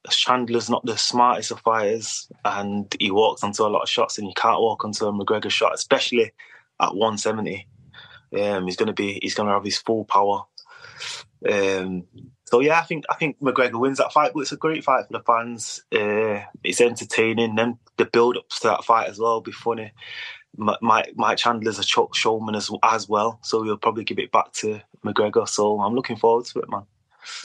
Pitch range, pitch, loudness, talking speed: 105-125 Hz, 115 Hz, -22 LUFS, 205 wpm